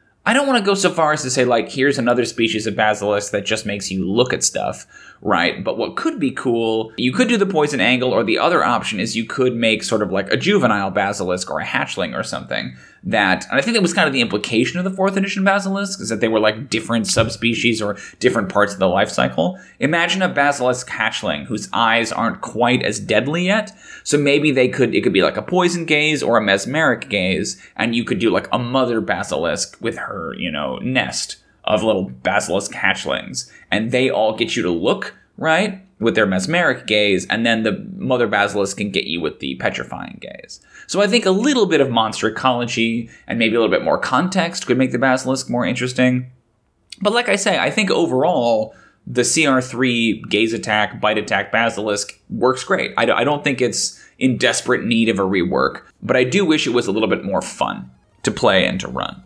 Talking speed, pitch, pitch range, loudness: 215 wpm, 125 Hz, 110-160 Hz, -18 LUFS